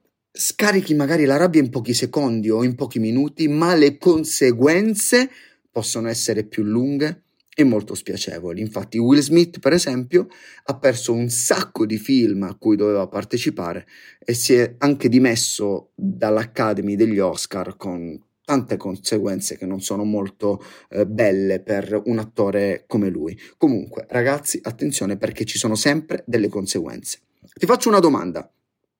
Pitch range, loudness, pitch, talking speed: 105-145 Hz, -20 LUFS, 120 Hz, 145 wpm